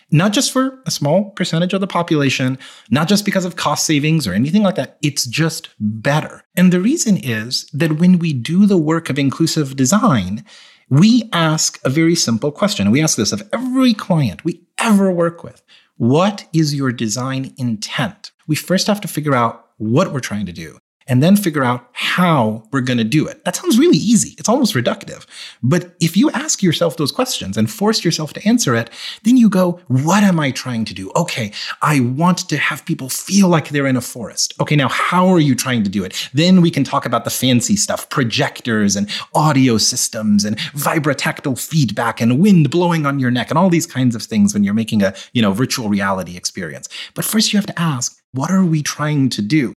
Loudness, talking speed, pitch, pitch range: -16 LUFS, 210 wpm, 155 Hz, 125-180 Hz